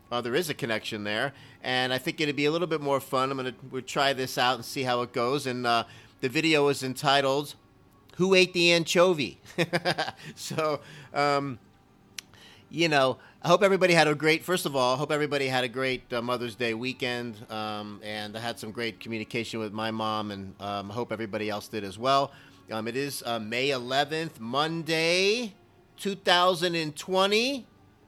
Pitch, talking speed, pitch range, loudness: 130 Hz, 190 wpm, 115-155 Hz, -27 LUFS